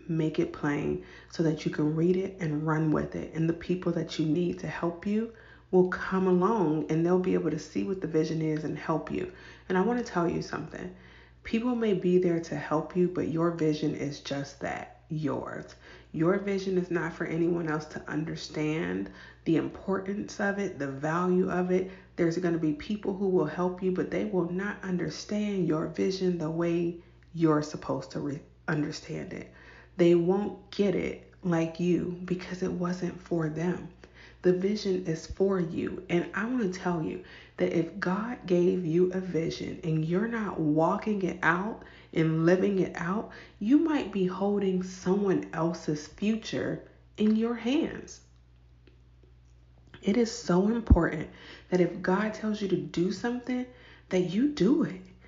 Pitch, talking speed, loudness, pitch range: 175 Hz, 180 wpm, -29 LUFS, 155-190 Hz